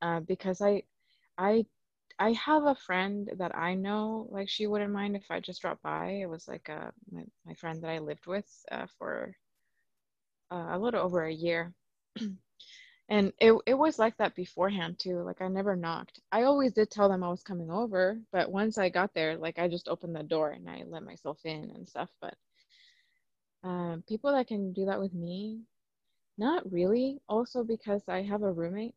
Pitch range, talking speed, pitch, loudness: 175-220 Hz, 195 wpm, 195 Hz, -31 LUFS